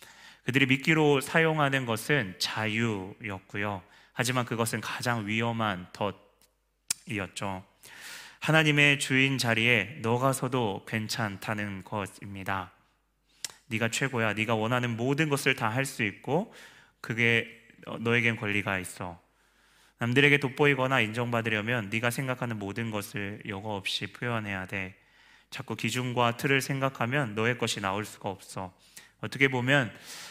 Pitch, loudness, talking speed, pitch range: 115 Hz, -28 LUFS, 280 characters per minute, 105-130 Hz